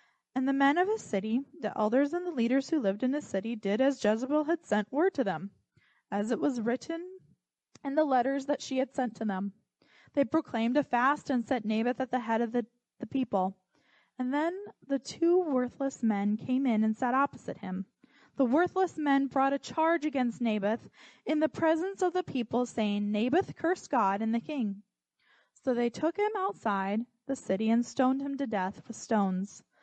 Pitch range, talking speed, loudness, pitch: 220-290 Hz, 195 wpm, -30 LUFS, 255 Hz